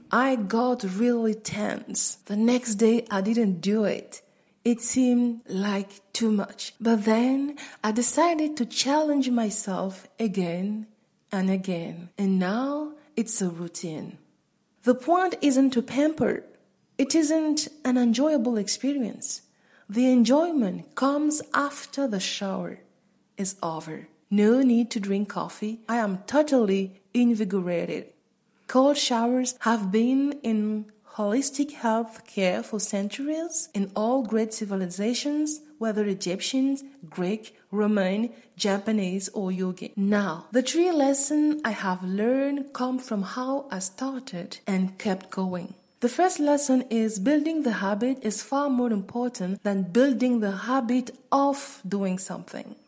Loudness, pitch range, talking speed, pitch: -25 LUFS, 200-265 Hz, 125 wpm, 230 Hz